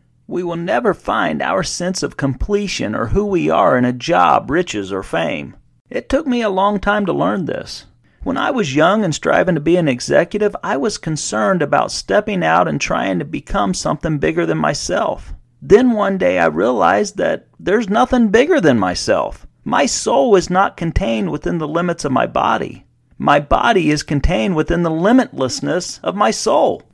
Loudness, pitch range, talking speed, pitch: -16 LUFS, 155-205 Hz, 185 wpm, 180 Hz